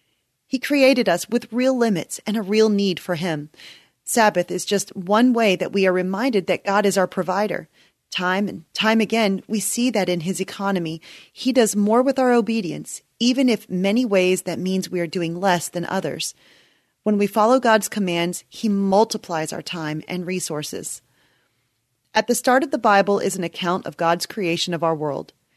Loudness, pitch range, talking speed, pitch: -21 LUFS, 175-220 Hz, 190 wpm, 195 Hz